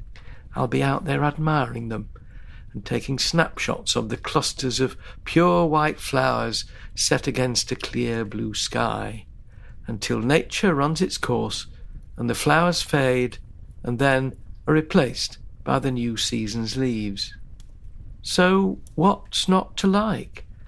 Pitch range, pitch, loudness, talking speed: 105-140 Hz, 120 Hz, -23 LUFS, 130 wpm